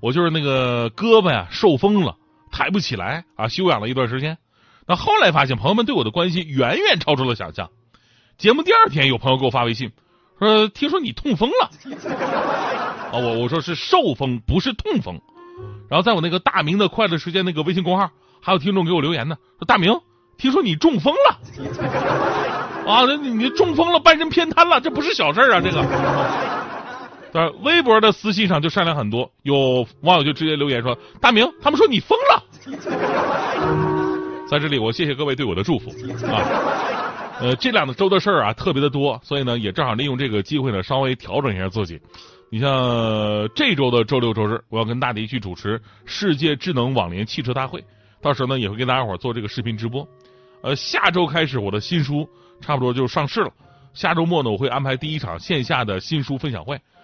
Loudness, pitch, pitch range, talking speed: -19 LUFS, 145 Hz, 120-185 Hz, 305 characters per minute